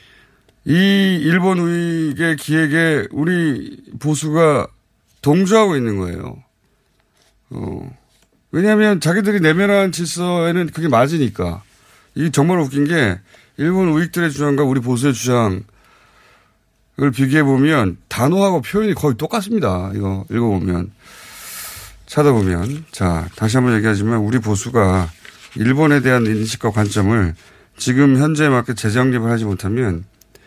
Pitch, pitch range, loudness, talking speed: 135 Hz, 110-160 Hz, -16 LUFS, 275 characters per minute